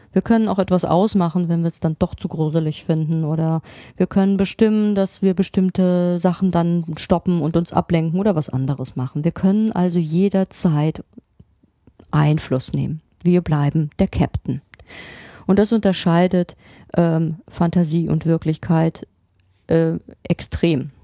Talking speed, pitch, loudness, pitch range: 140 wpm, 170 Hz, -19 LUFS, 160-185 Hz